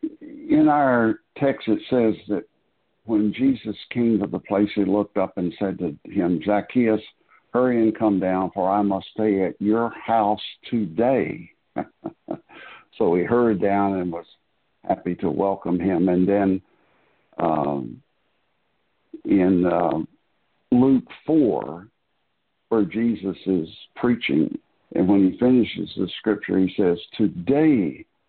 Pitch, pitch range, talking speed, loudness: 105 Hz, 95-120 Hz, 130 wpm, -22 LUFS